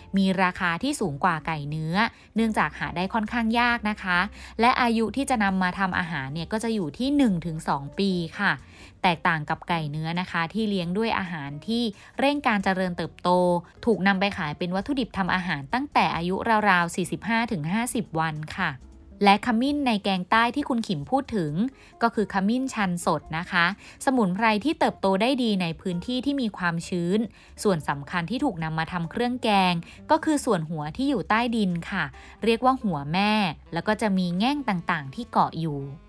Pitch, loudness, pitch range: 195 Hz, -25 LUFS, 175-230 Hz